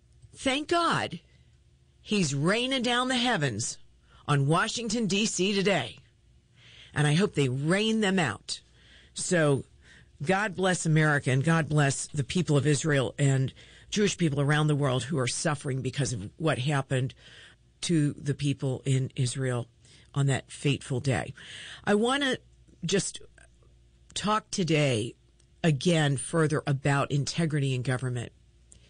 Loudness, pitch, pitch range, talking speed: -27 LUFS, 145 Hz, 130-180 Hz, 130 wpm